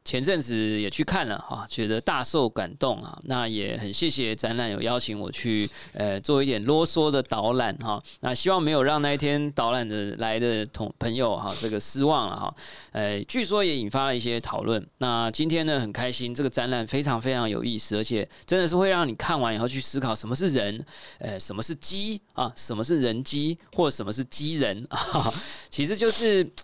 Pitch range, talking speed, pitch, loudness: 110-155 Hz, 295 characters per minute, 125 Hz, -26 LUFS